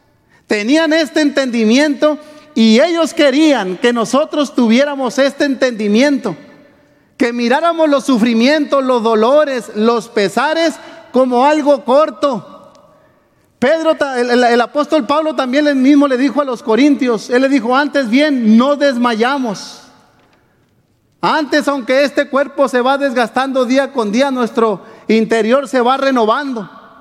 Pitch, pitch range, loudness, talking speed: 270 Hz, 235-290 Hz, -13 LUFS, 130 wpm